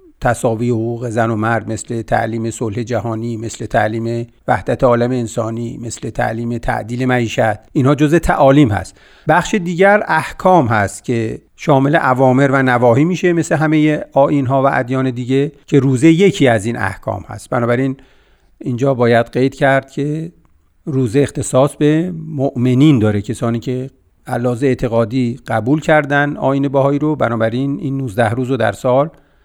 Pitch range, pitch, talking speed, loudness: 115-145 Hz, 130 Hz, 150 wpm, -15 LUFS